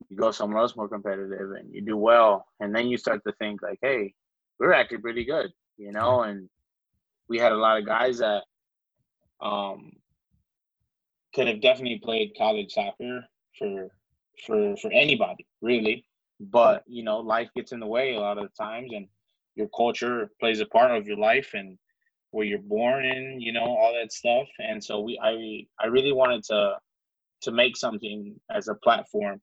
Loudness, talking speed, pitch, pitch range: -25 LUFS, 185 wpm, 110 Hz, 105-125 Hz